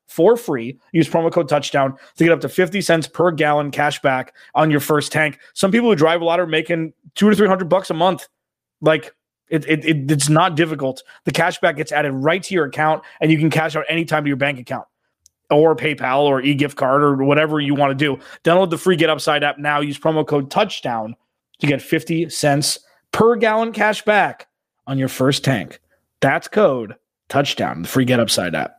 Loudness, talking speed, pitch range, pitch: -18 LUFS, 215 wpm, 145-170 Hz, 155 Hz